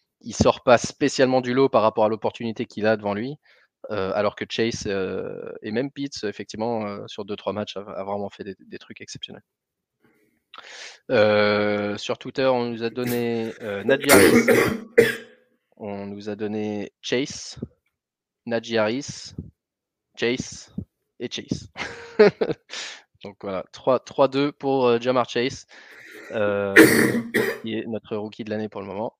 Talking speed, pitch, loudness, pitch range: 150 wpm, 115 Hz, -22 LUFS, 105-130 Hz